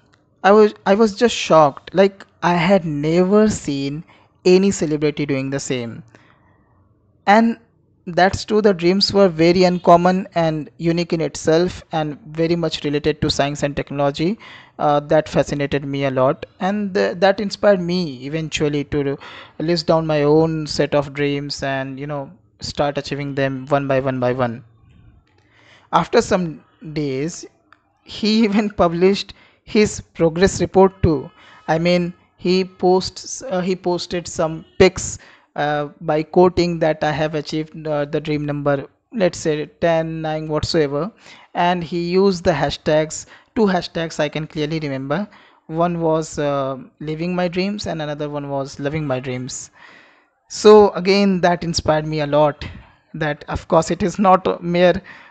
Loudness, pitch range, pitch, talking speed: -18 LUFS, 145-180 Hz, 160 Hz, 150 wpm